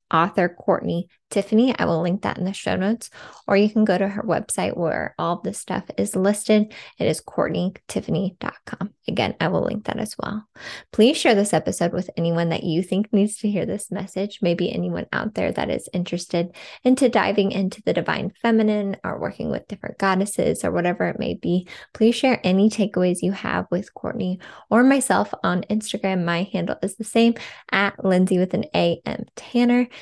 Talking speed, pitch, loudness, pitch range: 190 wpm, 195 Hz, -22 LUFS, 180-220 Hz